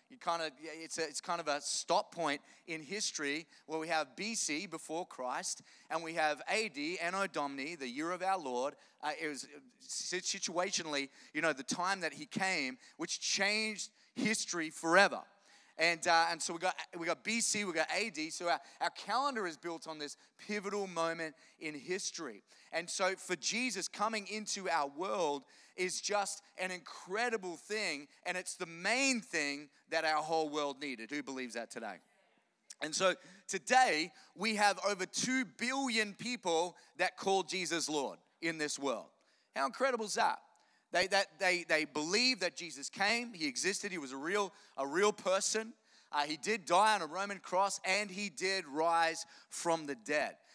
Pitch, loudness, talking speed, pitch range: 180 Hz, -35 LUFS, 175 wpm, 160-205 Hz